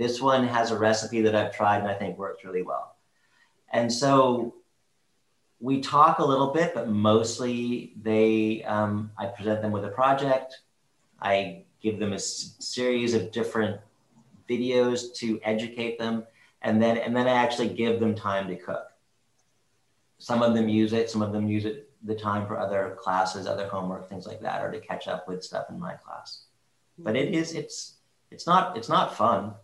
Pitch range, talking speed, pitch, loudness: 105-120 Hz, 185 wpm, 110 Hz, -26 LUFS